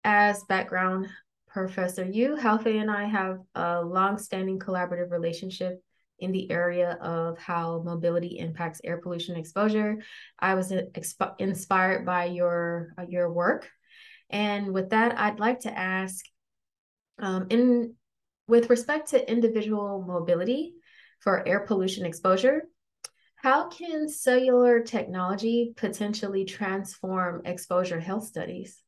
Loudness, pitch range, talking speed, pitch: -27 LUFS, 180-225 Hz, 115 wpm, 190 Hz